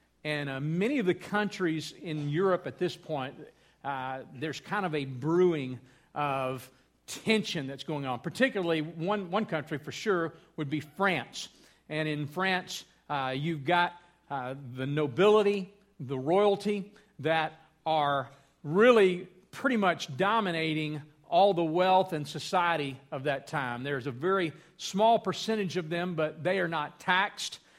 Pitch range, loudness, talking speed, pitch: 145-185 Hz, -30 LUFS, 145 wpm, 160 Hz